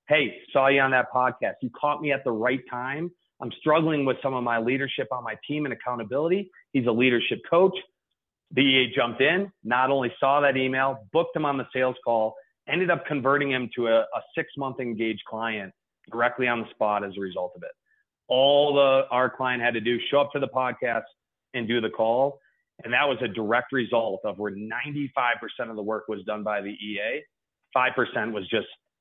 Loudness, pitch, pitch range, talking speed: -25 LUFS, 130 Hz, 120-145 Hz, 205 wpm